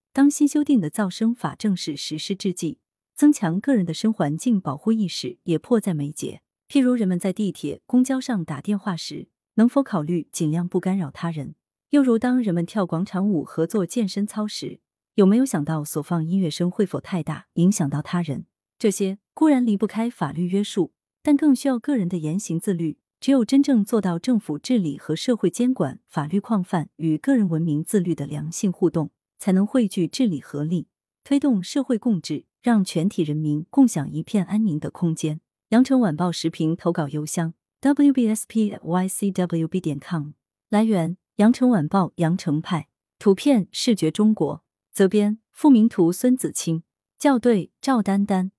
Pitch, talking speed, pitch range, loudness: 190 Hz, 275 characters per minute, 165-225 Hz, -22 LUFS